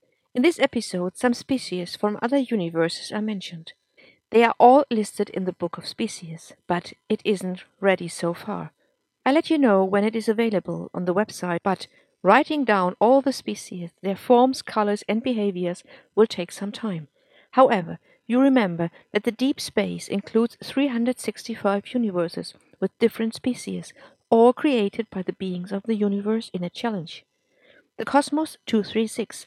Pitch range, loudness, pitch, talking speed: 185-240 Hz, -23 LUFS, 210 Hz, 160 wpm